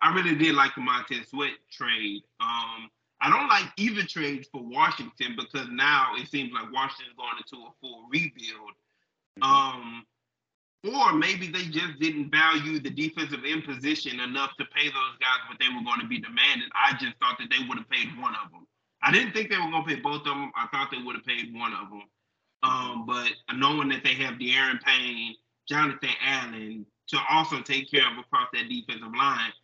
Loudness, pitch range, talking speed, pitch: -26 LUFS, 115-160 Hz, 200 wpm, 140 Hz